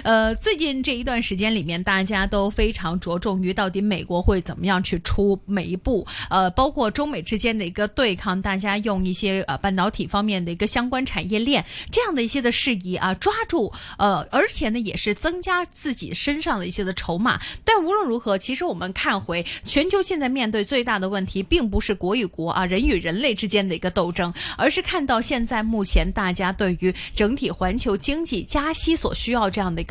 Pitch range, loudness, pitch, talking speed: 185-260 Hz, -22 LUFS, 210 Hz, 320 characters per minute